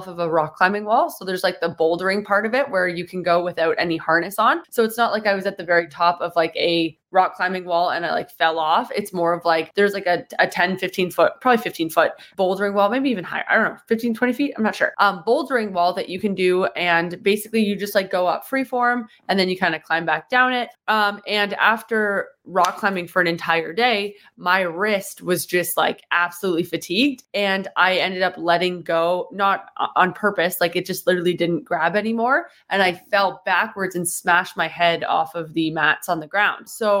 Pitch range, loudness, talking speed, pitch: 170-205 Hz, -20 LUFS, 230 wpm, 185 Hz